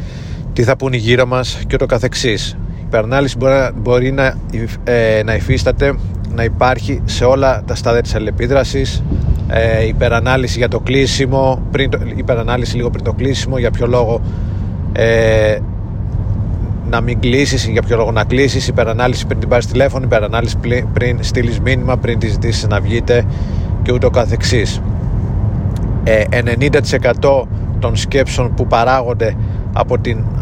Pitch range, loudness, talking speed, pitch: 105-125 Hz, -14 LUFS, 150 wpm, 115 Hz